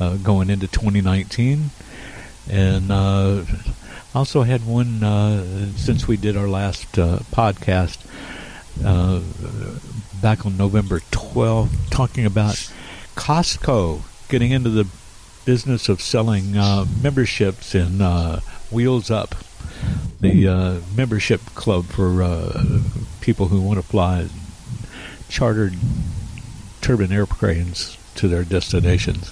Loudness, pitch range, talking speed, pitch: -20 LUFS, 95-115 Hz, 110 wpm, 100 Hz